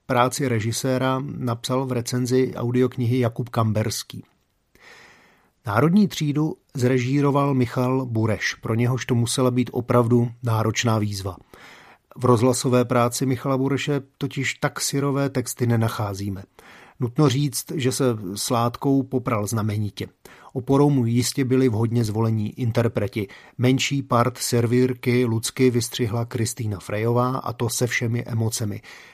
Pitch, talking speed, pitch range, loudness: 125 Hz, 115 wpm, 115-130 Hz, -22 LUFS